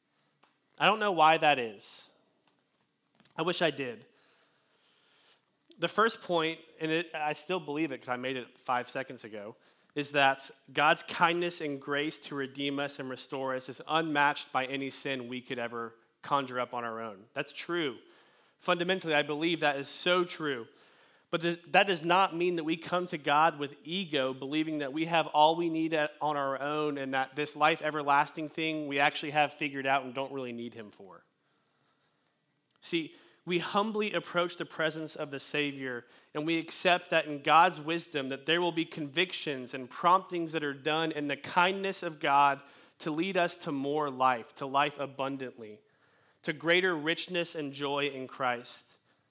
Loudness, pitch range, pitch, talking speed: -31 LUFS, 140-170 Hz, 150 Hz, 180 wpm